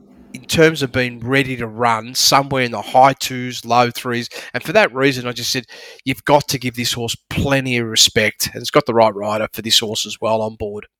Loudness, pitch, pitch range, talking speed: -17 LUFS, 125 Hz, 115-135 Hz, 230 wpm